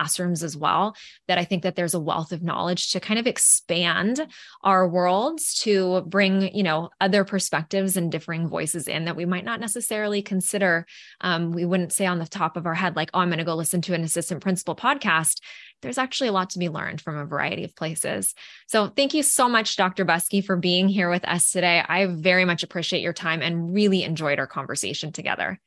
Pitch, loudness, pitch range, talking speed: 180 Hz, -23 LUFS, 165-195 Hz, 215 wpm